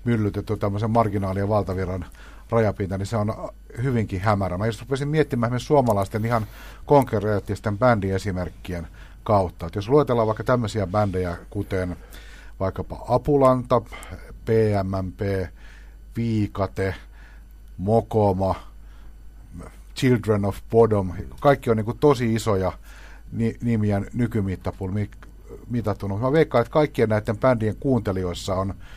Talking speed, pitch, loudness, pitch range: 105 wpm, 105 Hz, -23 LUFS, 95-115 Hz